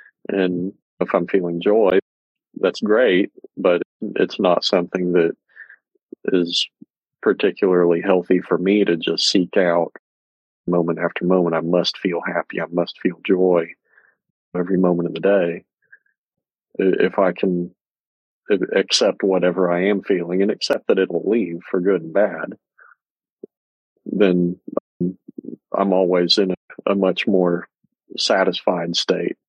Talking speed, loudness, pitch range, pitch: 130 wpm, -19 LUFS, 85-95 Hz, 90 Hz